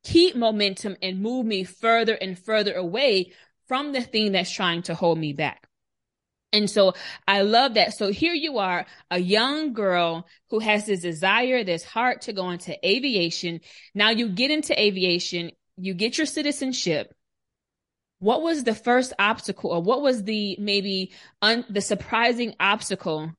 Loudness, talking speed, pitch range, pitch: -23 LUFS, 160 wpm, 180-235 Hz, 205 Hz